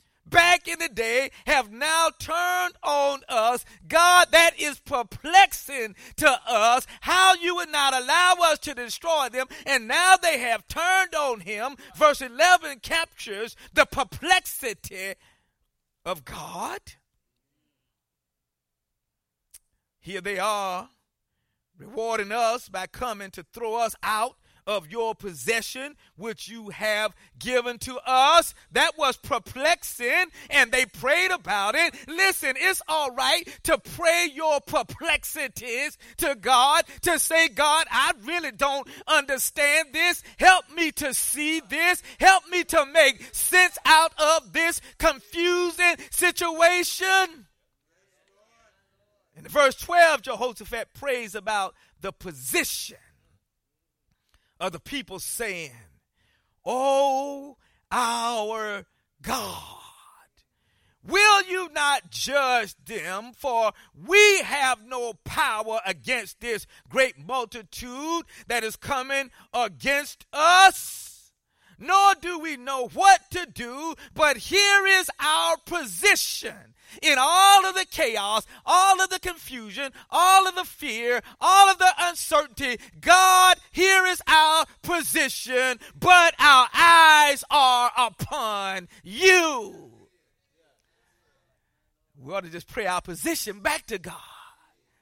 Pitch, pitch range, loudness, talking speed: 285 Hz, 230-345 Hz, -21 LUFS, 115 wpm